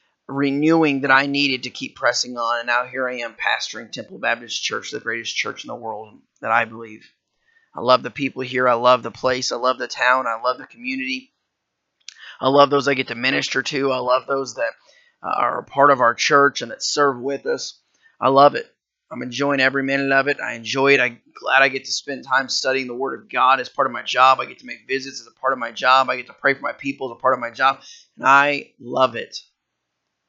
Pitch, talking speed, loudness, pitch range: 135 Hz, 245 wpm, -19 LUFS, 125-140 Hz